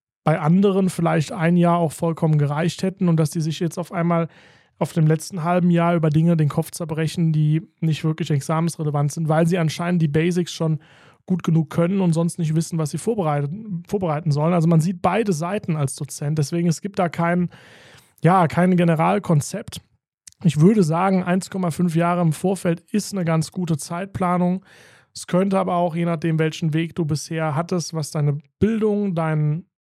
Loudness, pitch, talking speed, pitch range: -21 LUFS, 170 Hz, 185 wpm, 160-180 Hz